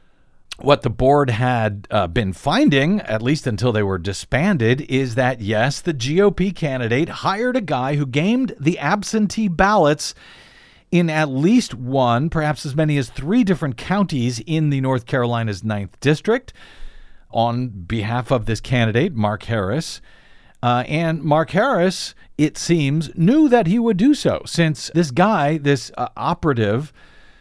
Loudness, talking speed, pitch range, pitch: -19 LUFS, 150 wpm, 120-170 Hz, 145 Hz